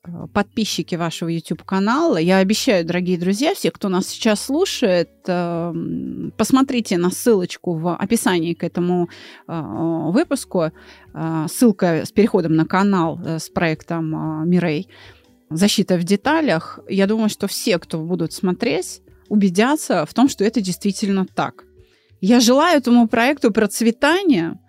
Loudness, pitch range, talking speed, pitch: -19 LUFS, 170-230 Hz, 120 wpm, 190 Hz